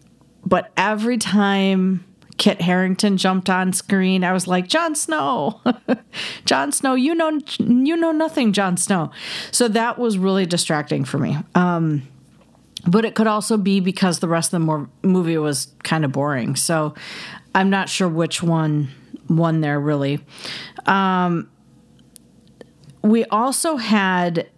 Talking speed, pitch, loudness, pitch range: 140 wpm, 185 Hz, -19 LUFS, 165-215 Hz